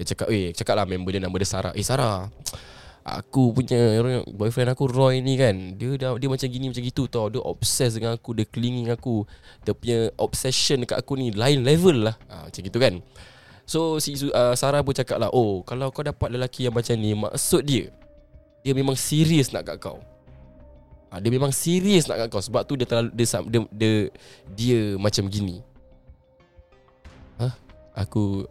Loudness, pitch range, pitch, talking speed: -23 LUFS, 100-130 Hz, 115 Hz, 195 wpm